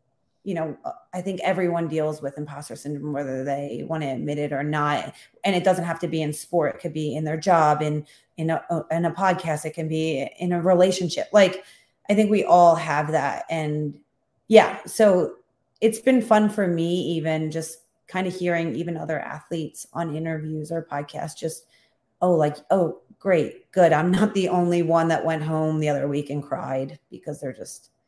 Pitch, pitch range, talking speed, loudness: 160 Hz, 150-180 Hz, 195 wpm, -23 LUFS